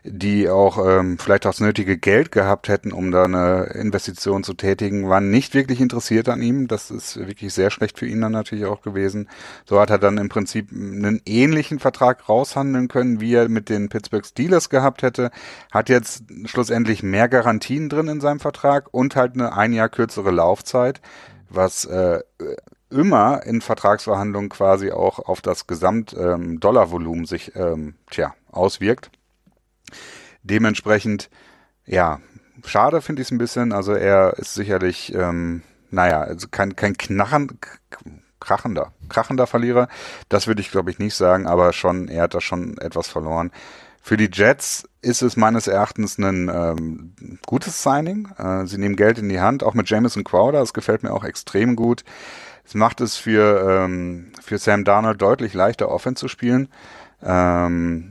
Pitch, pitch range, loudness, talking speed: 105 Hz, 95-120 Hz, -19 LUFS, 165 wpm